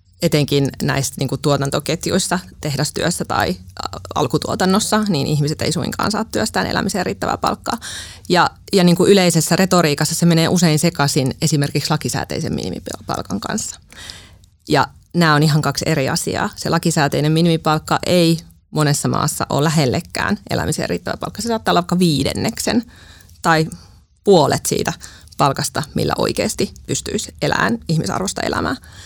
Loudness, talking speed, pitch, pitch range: -18 LUFS, 130 wpm, 155 Hz, 140-175 Hz